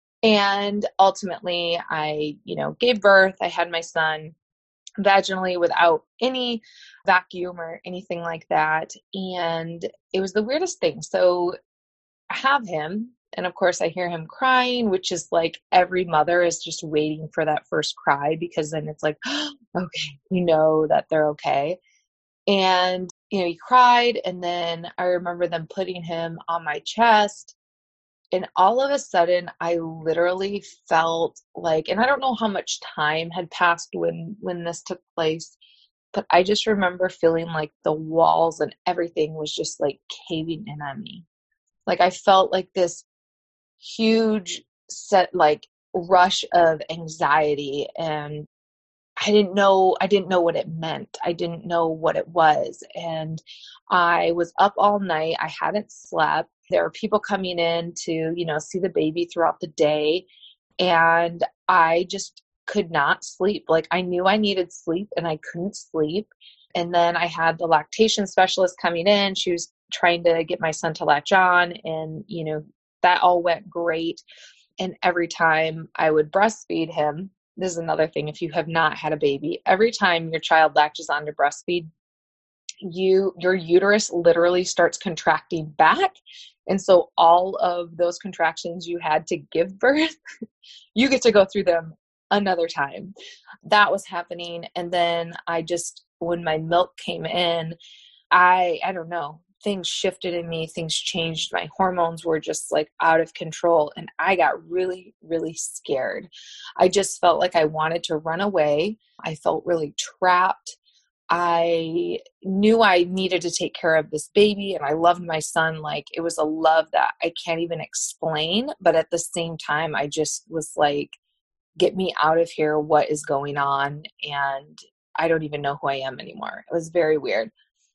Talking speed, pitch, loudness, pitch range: 170 wpm, 170 Hz, -22 LUFS, 160-190 Hz